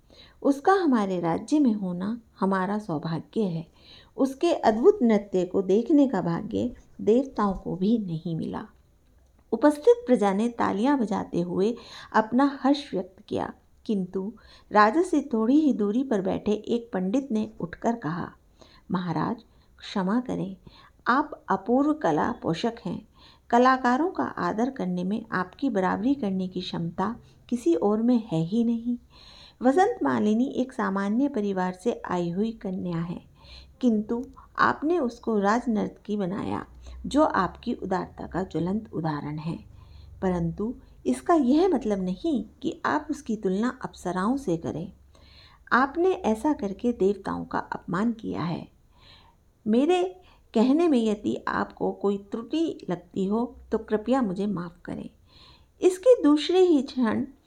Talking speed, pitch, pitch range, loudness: 135 wpm, 220 Hz, 190-260 Hz, -26 LUFS